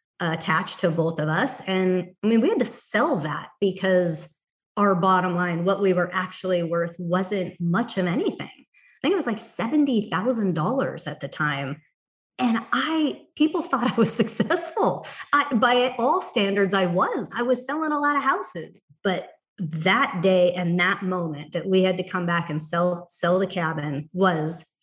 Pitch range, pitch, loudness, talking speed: 175-230 Hz, 185 Hz, -24 LUFS, 175 wpm